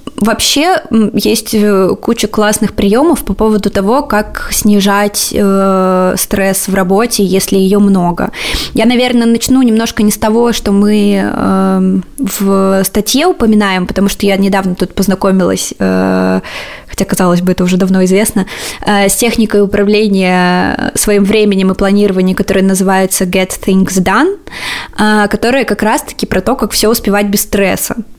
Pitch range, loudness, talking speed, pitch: 190-220 Hz, -10 LUFS, 145 wpm, 205 Hz